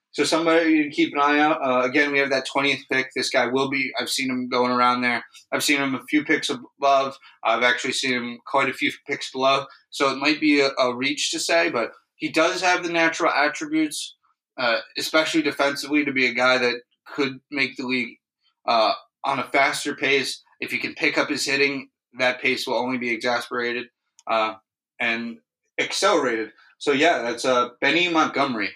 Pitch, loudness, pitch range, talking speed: 135 Hz, -22 LUFS, 125-150 Hz, 200 wpm